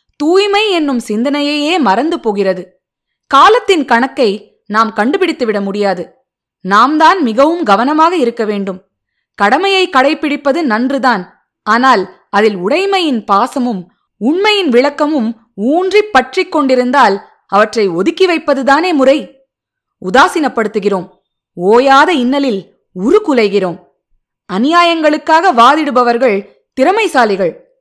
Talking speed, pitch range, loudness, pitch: 85 wpm, 210-315 Hz, -11 LUFS, 260 Hz